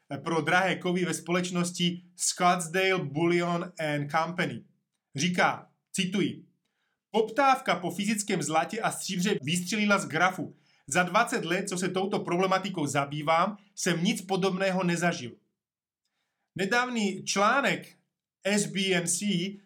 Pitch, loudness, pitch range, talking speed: 185 Hz, -28 LUFS, 170-195 Hz, 105 wpm